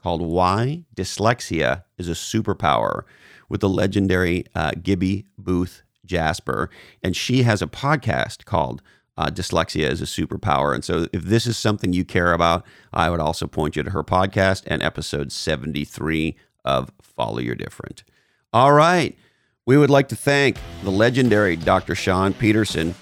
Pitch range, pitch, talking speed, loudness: 80-105 Hz, 90 Hz, 155 wpm, -21 LUFS